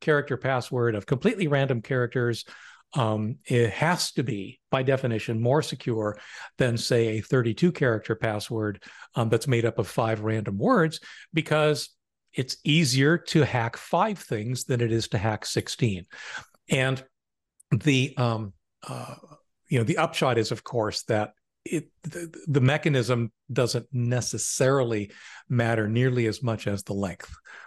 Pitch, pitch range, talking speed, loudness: 125 Hz, 115-145 Hz, 145 wpm, -26 LUFS